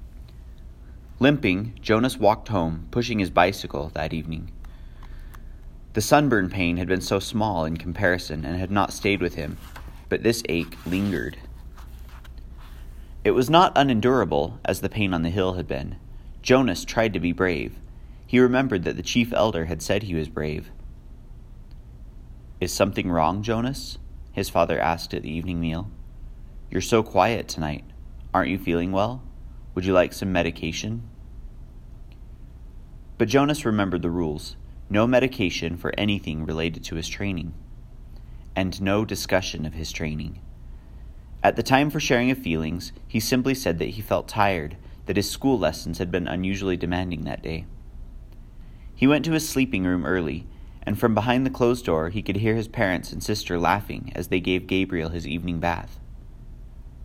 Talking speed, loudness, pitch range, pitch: 160 wpm, -24 LUFS, 70-100 Hz, 85 Hz